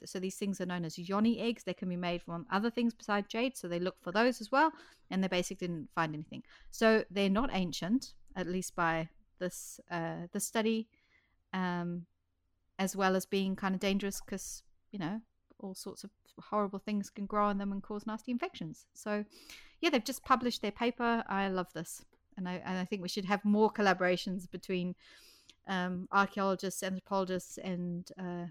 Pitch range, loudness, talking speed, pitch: 180-215 Hz, -34 LUFS, 190 wpm, 195 Hz